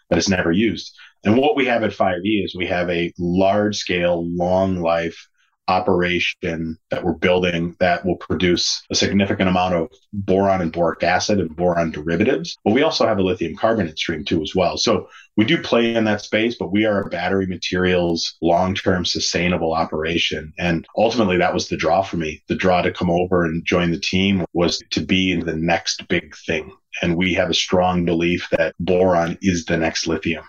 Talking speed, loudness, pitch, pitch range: 195 wpm, -19 LUFS, 90 Hz, 85-95 Hz